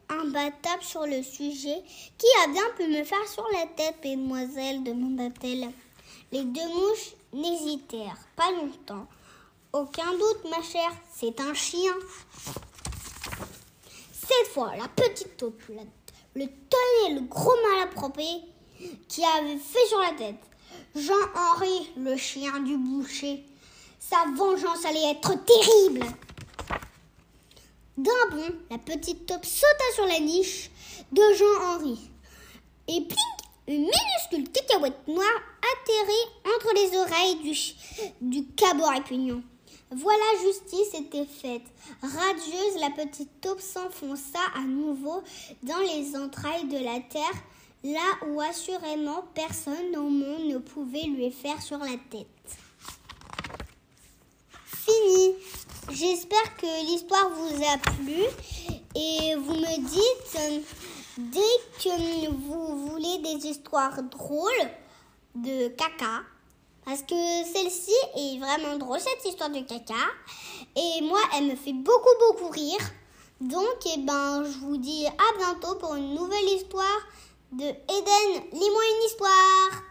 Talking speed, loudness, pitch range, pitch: 125 wpm, -26 LUFS, 280-385 Hz, 320 Hz